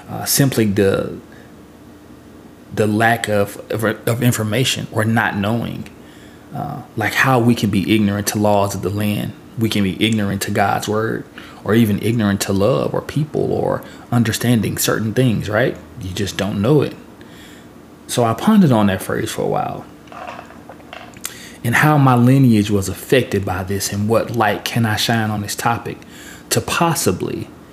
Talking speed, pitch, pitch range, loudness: 165 wpm, 105 Hz, 100-120 Hz, -17 LUFS